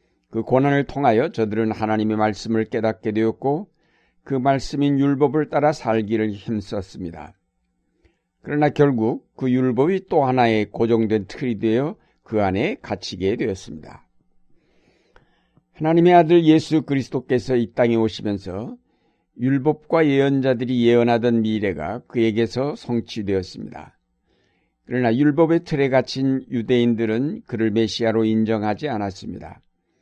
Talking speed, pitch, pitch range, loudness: 295 characters per minute, 120 Hz, 110-140 Hz, -20 LUFS